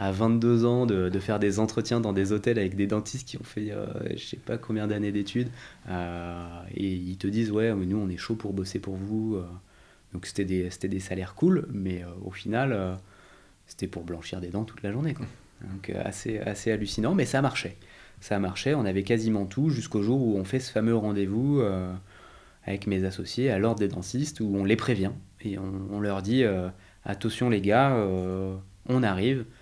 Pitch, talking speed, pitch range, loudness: 100 Hz, 210 wpm, 95-115 Hz, -28 LUFS